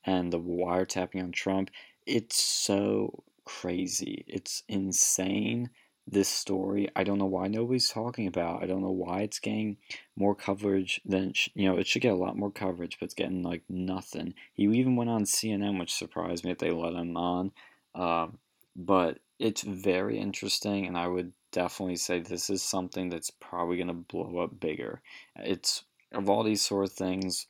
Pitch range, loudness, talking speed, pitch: 90-100 Hz, -30 LUFS, 175 wpm, 95 Hz